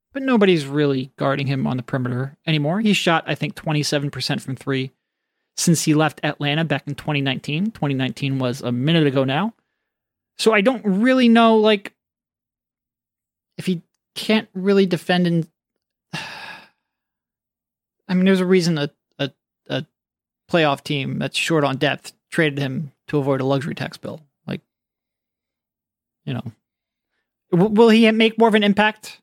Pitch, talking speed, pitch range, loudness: 165 Hz, 160 wpm, 140-210 Hz, -19 LUFS